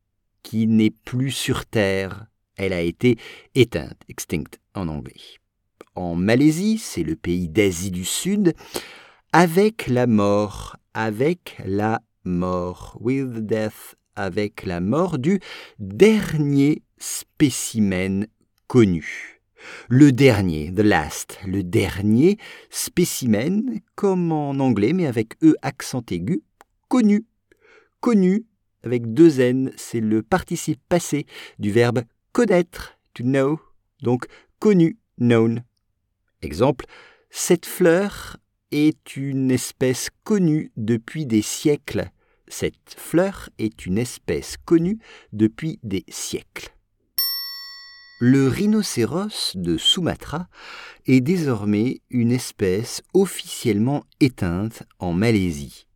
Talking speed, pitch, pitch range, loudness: 105 wpm, 125 Hz, 105-175 Hz, -21 LUFS